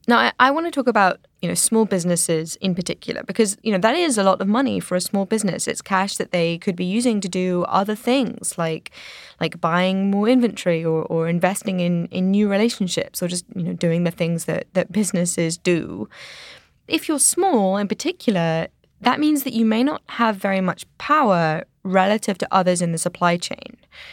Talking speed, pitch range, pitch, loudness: 205 wpm, 175-225 Hz, 195 Hz, -20 LUFS